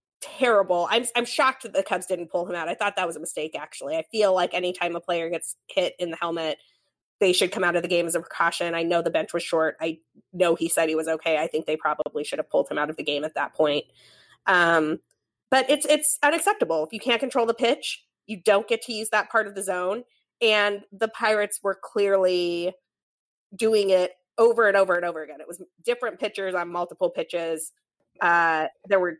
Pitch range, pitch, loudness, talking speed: 170-220 Hz, 180 Hz, -24 LUFS, 230 wpm